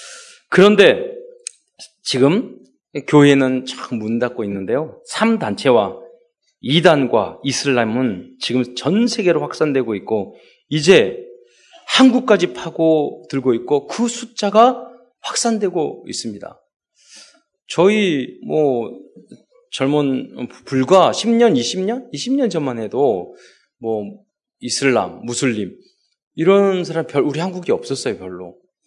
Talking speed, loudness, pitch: 200 characters per minute, -17 LUFS, 195 Hz